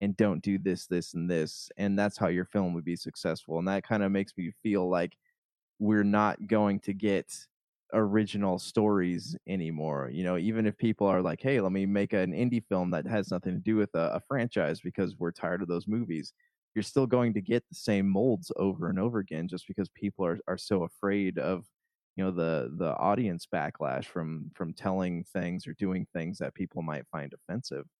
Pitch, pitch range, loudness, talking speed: 95 Hz, 90-105 Hz, -31 LUFS, 210 wpm